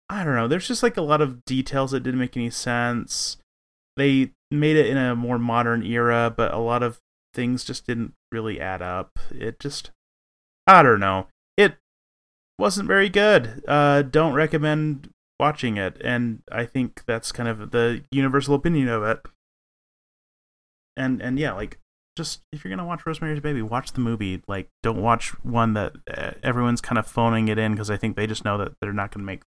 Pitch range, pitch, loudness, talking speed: 110-140 Hz, 120 Hz, -23 LUFS, 195 wpm